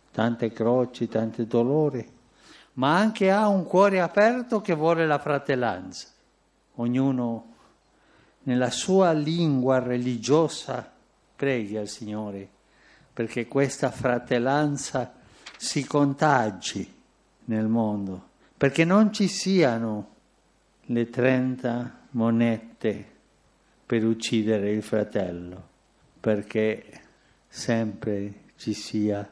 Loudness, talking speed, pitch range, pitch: -25 LUFS, 90 wpm, 110-145 Hz, 125 Hz